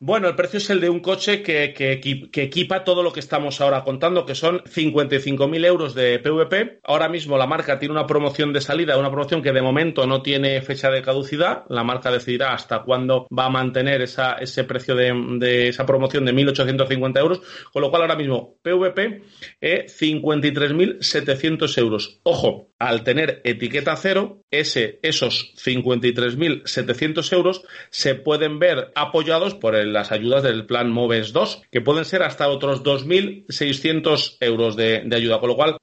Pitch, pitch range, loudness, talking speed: 140 Hz, 130-165 Hz, -20 LUFS, 175 wpm